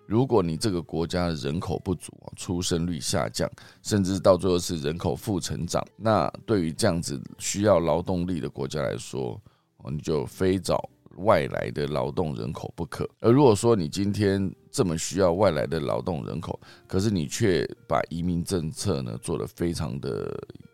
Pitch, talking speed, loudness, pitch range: 85 Hz, 260 characters per minute, -26 LUFS, 80-95 Hz